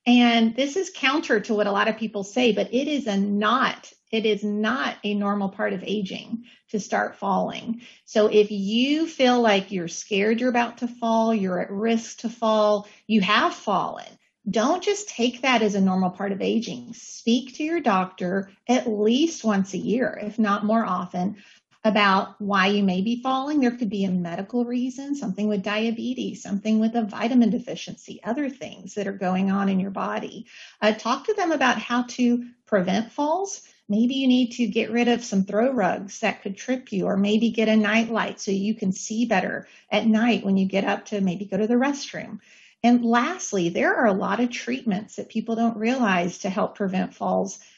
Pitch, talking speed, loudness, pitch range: 220 Hz, 200 wpm, -23 LUFS, 205-240 Hz